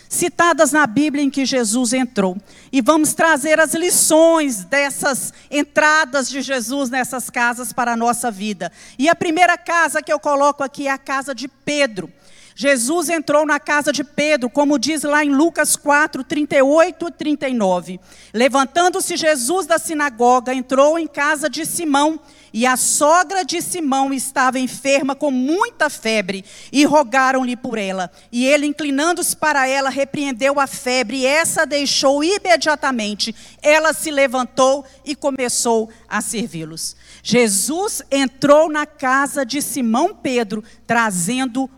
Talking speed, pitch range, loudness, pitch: 145 wpm, 255-305 Hz, -17 LUFS, 280 Hz